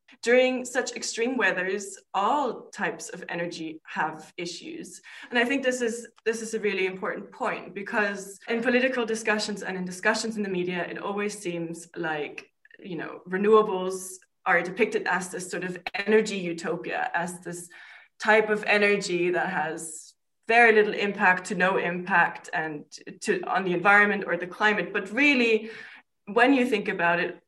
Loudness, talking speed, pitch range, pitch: -25 LUFS, 160 wpm, 180-225 Hz, 205 Hz